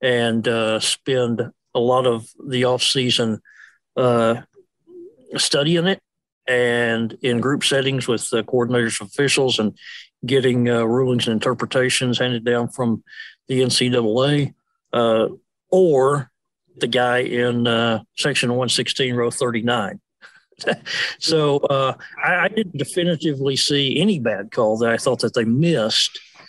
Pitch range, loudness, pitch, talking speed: 120-135 Hz, -19 LUFS, 125 Hz, 130 wpm